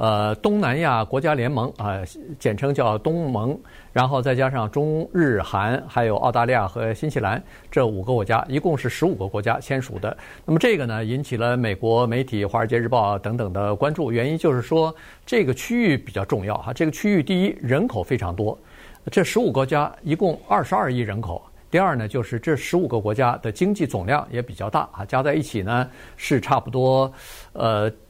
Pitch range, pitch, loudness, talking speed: 110-145 Hz, 125 Hz, -22 LUFS, 300 characters per minute